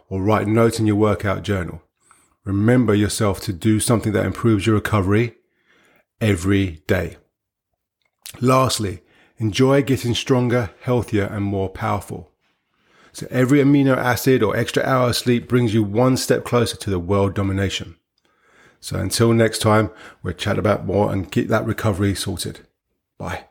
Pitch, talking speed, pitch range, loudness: 110 Hz, 150 wpm, 100-120 Hz, -19 LUFS